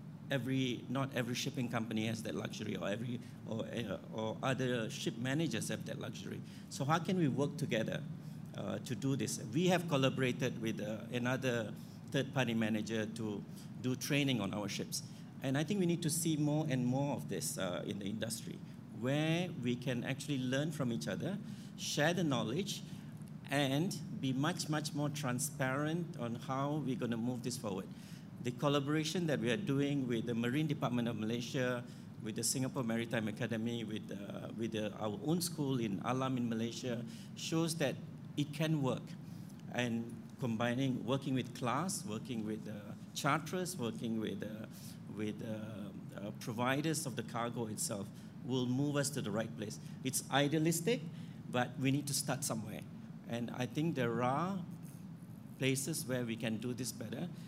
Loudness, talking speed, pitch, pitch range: -38 LUFS, 170 wpm, 135 Hz, 120-165 Hz